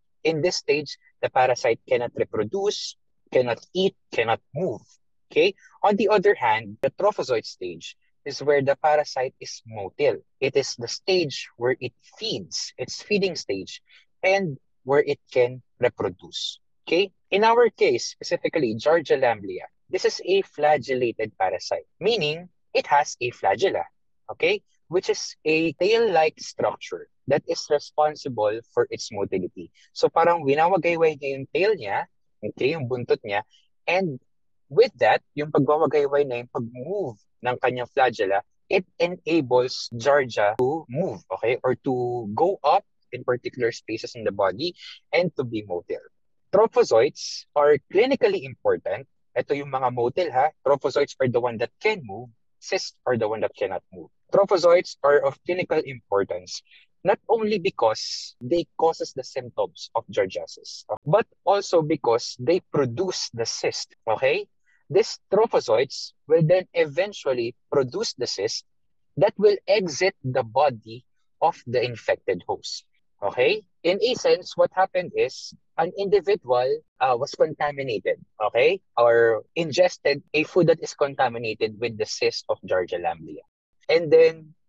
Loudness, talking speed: -24 LUFS, 145 wpm